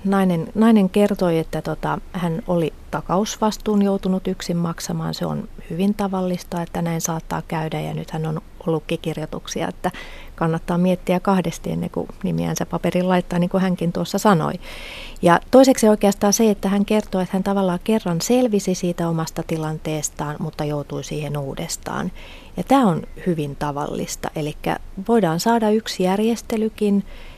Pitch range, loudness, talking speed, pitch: 160-200 Hz, -21 LUFS, 150 wpm, 180 Hz